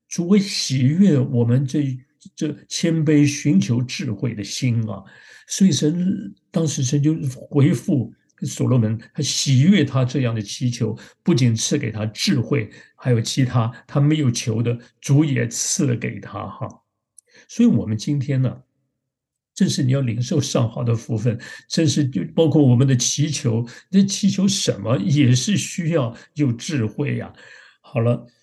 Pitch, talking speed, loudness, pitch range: 135 Hz, 225 characters per minute, -20 LUFS, 120-155 Hz